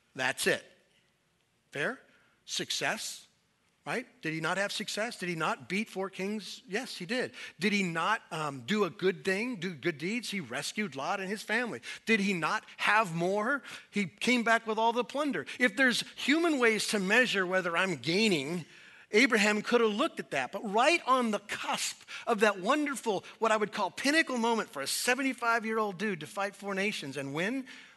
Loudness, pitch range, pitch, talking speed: -30 LUFS, 190-235 Hz, 210 Hz, 190 wpm